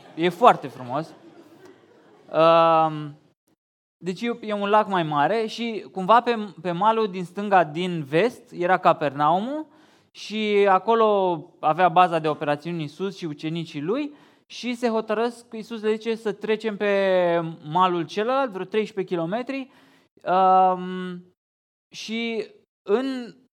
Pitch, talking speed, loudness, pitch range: 190 Hz, 115 wpm, -23 LUFS, 170-225 Hz